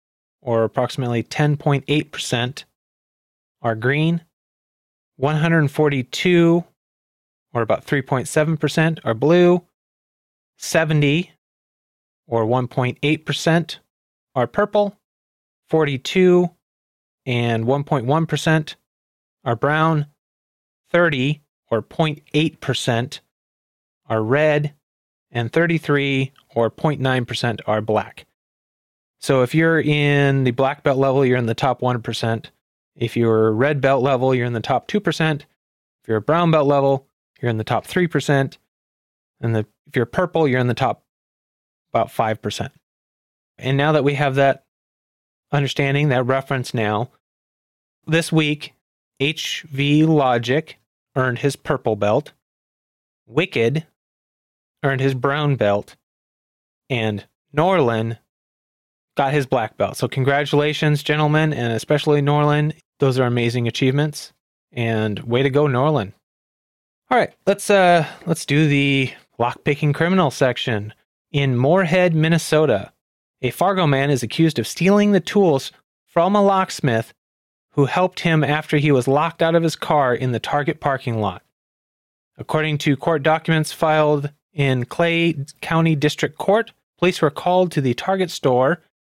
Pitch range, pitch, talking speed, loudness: 120-155 Hz, 140 Hz, 125 wpm, -19 LUFS